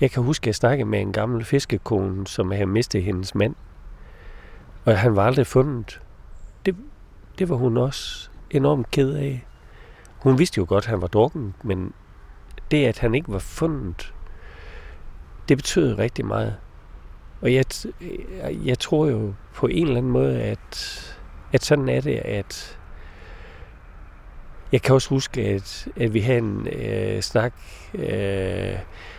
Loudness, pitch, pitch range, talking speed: -23 LUFS, 105 Hz, 90-130 Hz, 155 wpm